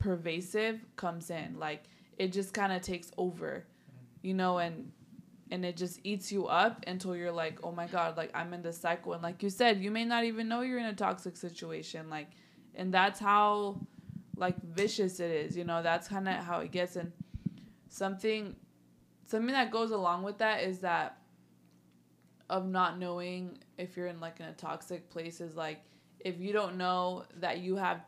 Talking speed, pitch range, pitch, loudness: 190 wpm, 170-195 Hz, 180 Hz, -34 LUFS